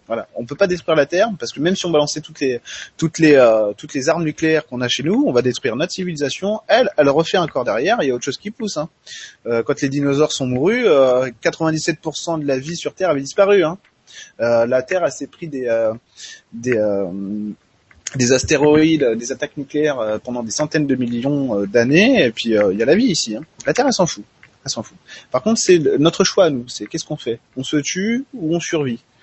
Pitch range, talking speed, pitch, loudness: 125-165 Hz, 245 wpm, 145 Hz, -18 LUFS